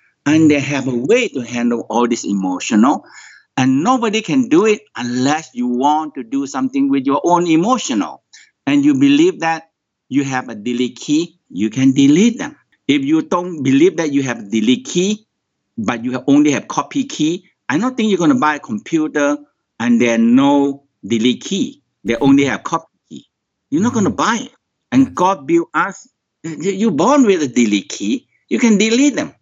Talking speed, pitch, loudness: 190 wpm, 155 Hz, -16 LUFS